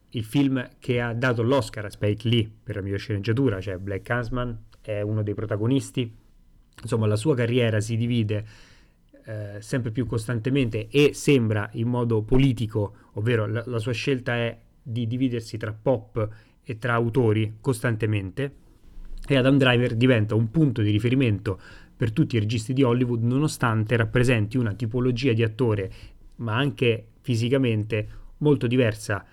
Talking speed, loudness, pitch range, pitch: 150 wpm, -24 LUFS, 110-130 Hz, 120 Hz